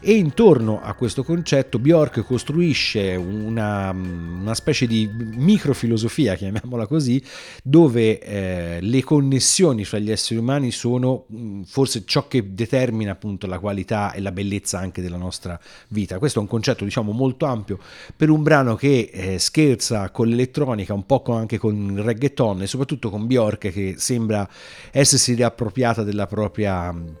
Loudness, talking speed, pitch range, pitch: -20 LUFS, 150 wpm, 100-130 Hz, 115 Hz